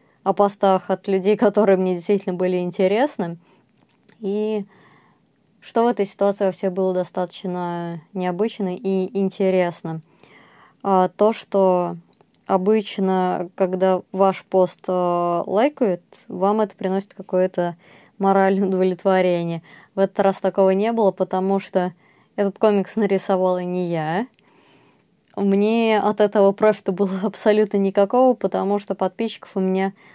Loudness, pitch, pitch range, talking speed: -21 LUFS, 195 Hz, 185-205 Hz, 115 wpm